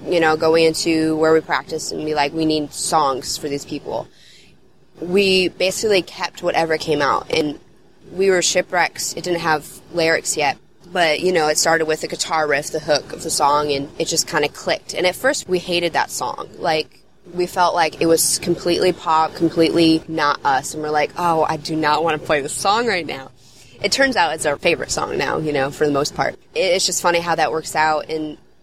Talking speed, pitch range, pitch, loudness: 220 wpm, 155-175 Hz, 160 Hz, -18 LUFS